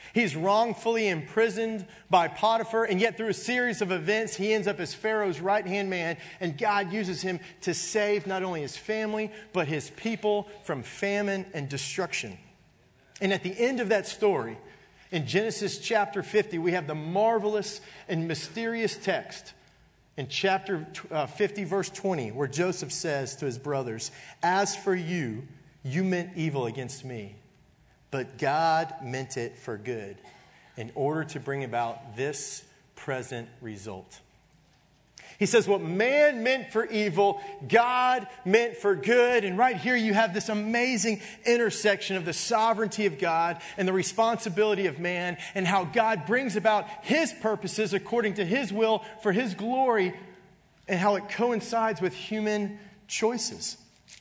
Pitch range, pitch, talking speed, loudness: 165-215 Hz, 195 Hz, 155 wpm, -28 LUFS